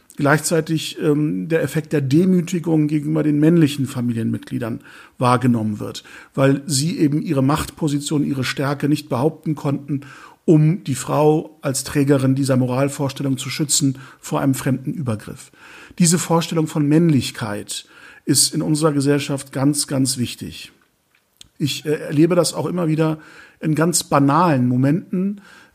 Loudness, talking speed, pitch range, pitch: -19 LUFS, 135 wpm, 135-155 Hz, 145 Hz